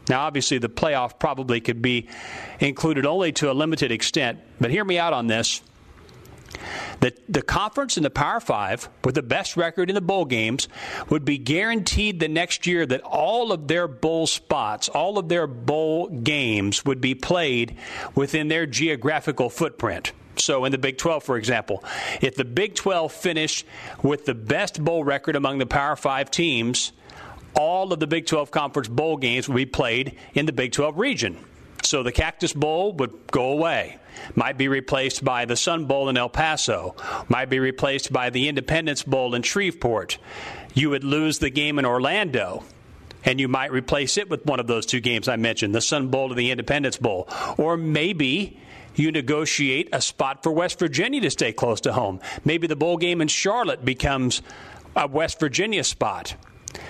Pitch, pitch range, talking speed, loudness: 145 Hz, 130-160 Hz, 185 wpm, -23 LUFS